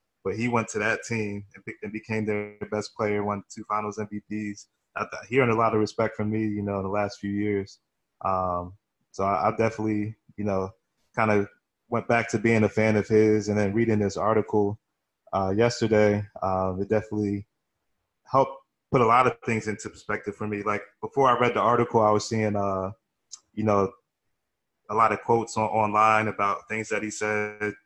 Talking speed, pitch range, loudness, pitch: 190 wpm, 100-110 Hz, -26 LUFS, 105 Hz